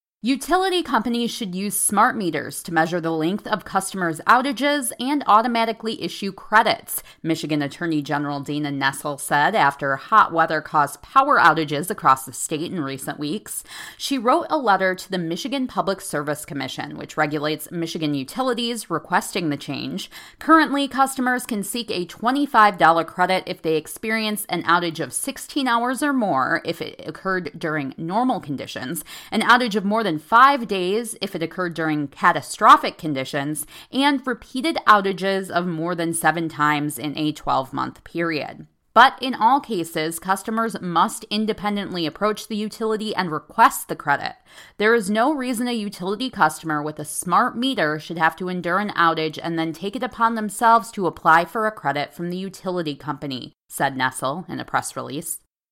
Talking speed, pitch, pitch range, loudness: 165 wpm, 180 Hz, 155-225 Hz, -21 LUFS